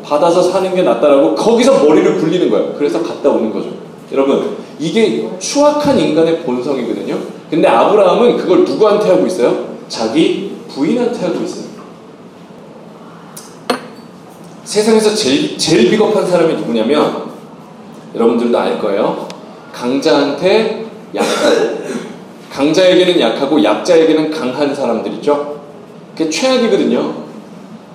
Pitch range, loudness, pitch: 155-220 Hz, -13 LUFS, 200 Hz